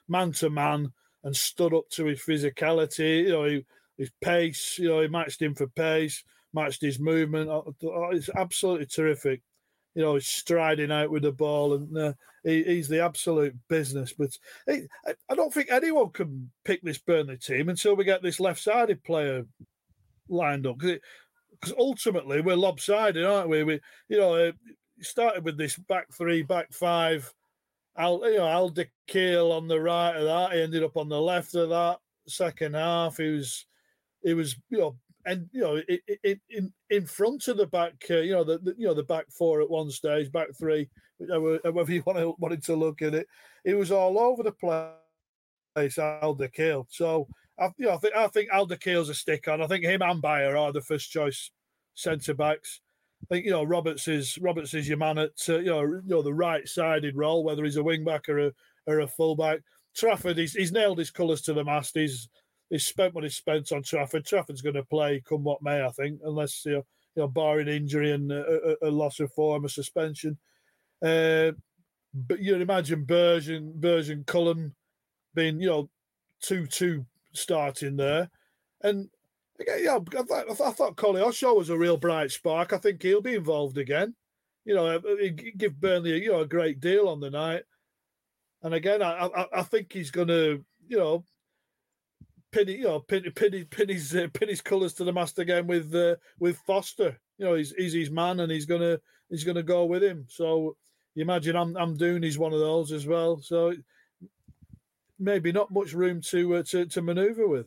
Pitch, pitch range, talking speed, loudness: 165 Hz, 150-180 Hz, 200 wpm, -27 LUFS